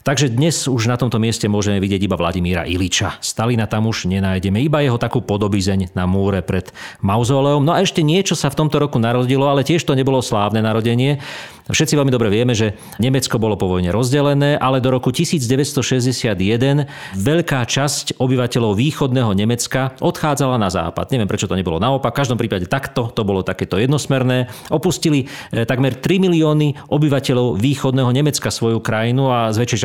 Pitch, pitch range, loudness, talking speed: 125 Hz, 110-140 Hz, -17 LUFS, 170 wpm